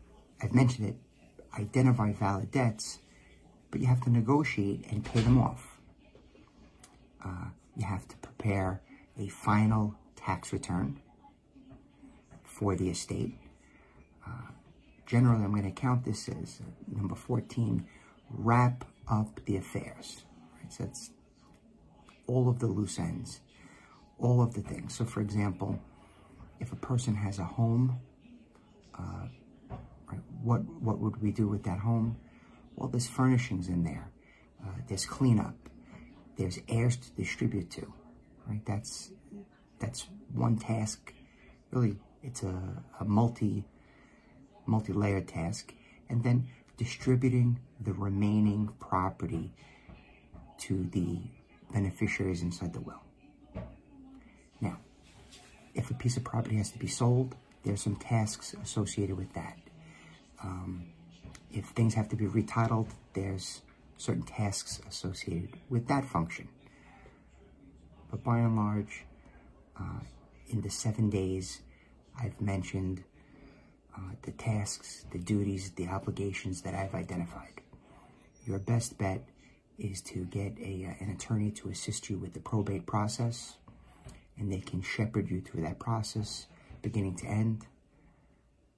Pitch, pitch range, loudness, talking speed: 105 Hz, 95-120 Hz, -33 LUFS, 125 wpm